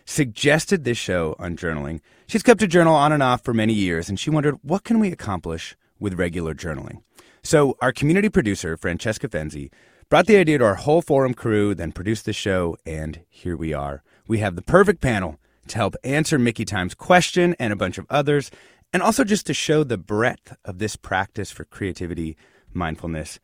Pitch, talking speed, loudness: 110 Hz, 195 wpm, -21 LUFS